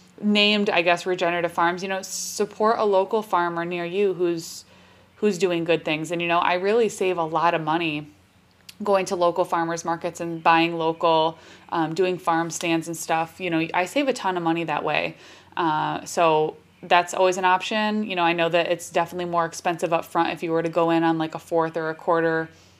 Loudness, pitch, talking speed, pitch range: -23 LUFS, 170 Hz, 215 wpm, 165-185 Hz